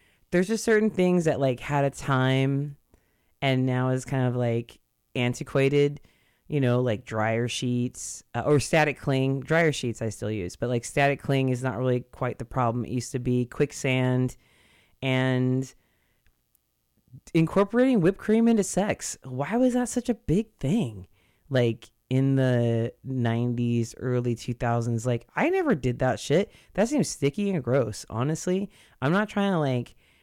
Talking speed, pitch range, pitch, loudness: 160 wpm, 120-150 Hz, 130 Hz, -26 LUFS